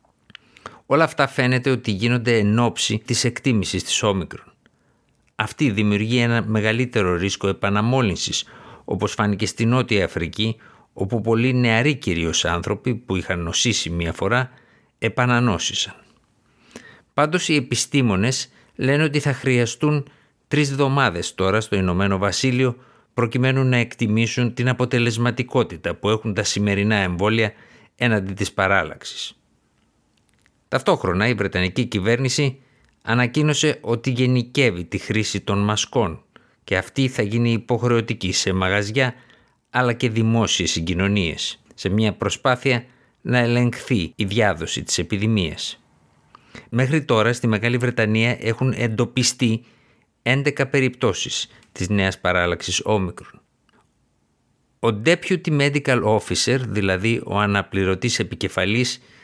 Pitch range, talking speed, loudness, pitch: 100-125 Hz, 110 wpm, -21 LUFS, 115 Hz